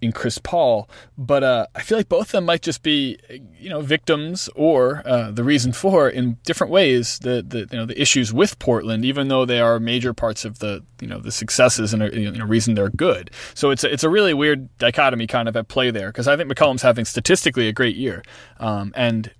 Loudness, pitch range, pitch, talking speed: -19 LUFS, 115-145 Hz, 125 Hz, 235 wpm